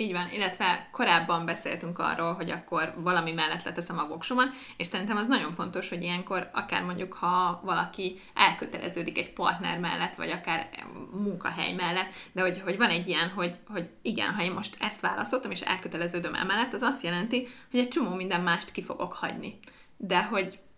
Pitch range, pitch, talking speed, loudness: 170-195 Hz, 180 Hz, 180 wpm, -29 LUFS